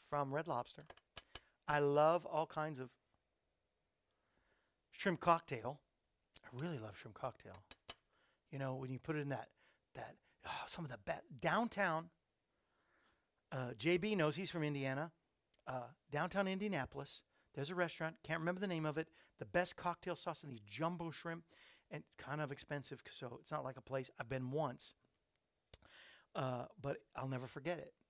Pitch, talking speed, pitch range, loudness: 150 Hz, 165 wpm, 130-170 Hz, -42 LUFS